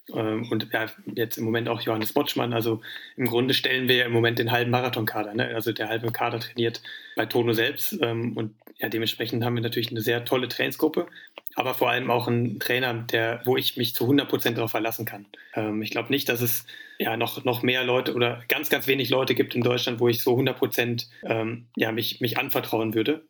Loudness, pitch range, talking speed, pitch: -25 LUFS, 115-125 Hz, 215 wpm, 120 Hz